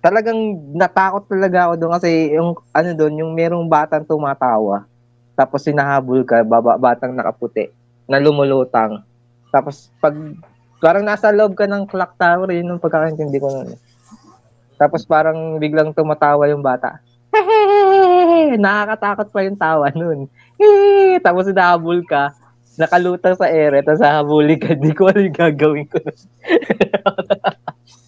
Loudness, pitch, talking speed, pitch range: -15 LUFS, 155 Hz, 135 wpm, 135-190 Hz